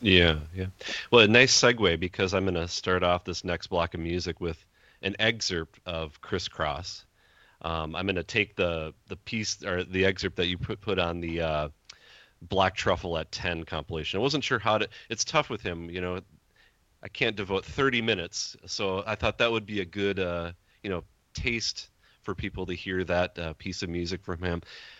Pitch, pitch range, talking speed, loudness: 90 Hz, 85-100 Hz, 205 wpm, -28 LUFS